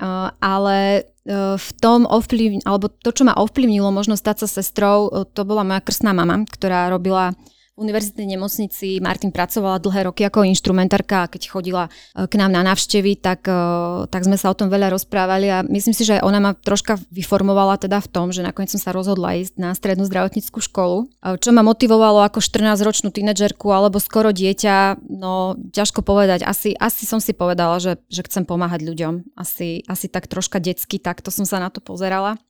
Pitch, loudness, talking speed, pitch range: 195 Hz, -18 LUFS, 185 wpm, 185-210 Hz